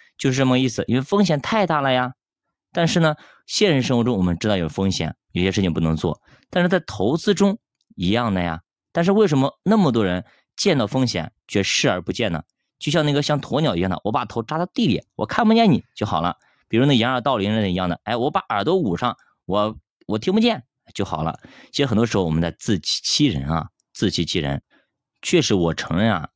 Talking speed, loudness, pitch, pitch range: 320 characters per minute, -21 LUFS, 120 Hz, 95-150 Hz